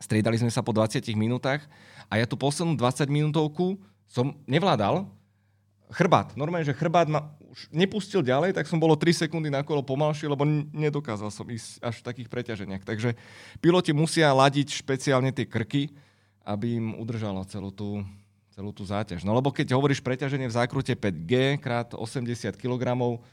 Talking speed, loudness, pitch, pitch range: 165 wpm, -26 LUFS, 125 Hz, 110-150 Hz